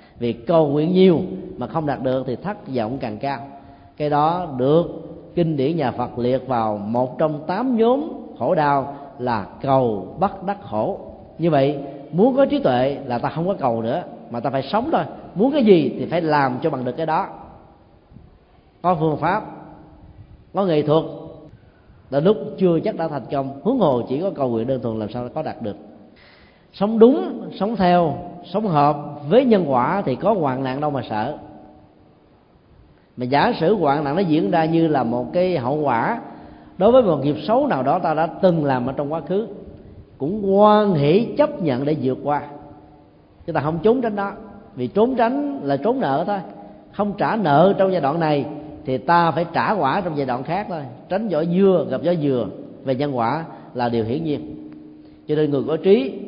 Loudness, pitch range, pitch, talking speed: -20 LUFS, 130-185 Hz, 150 Hz, 200 wpm